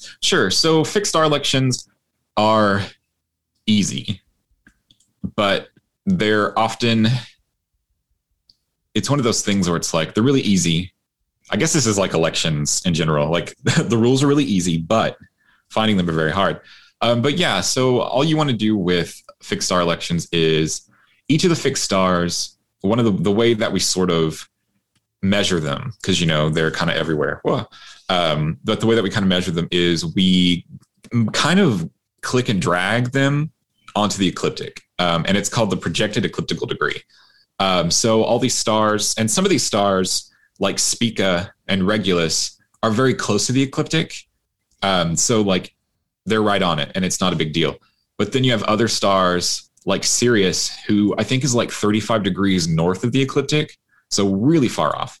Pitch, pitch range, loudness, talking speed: 105 Hz, 90-120 Hz, -19 LUFS, 180 wpm